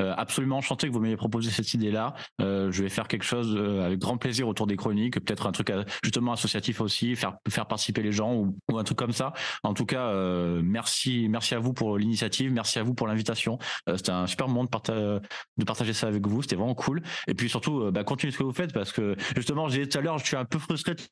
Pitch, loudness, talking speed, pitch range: 115 Hz, -28 LUFS, 265 wpm, 105-130 Hz